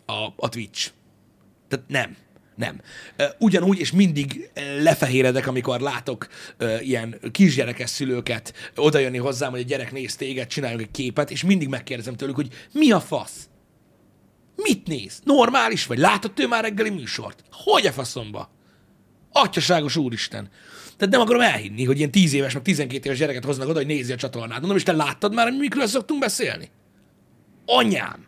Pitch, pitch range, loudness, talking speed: 145 Hz, 130-195 Hz, -22 LUFS, 160 wpm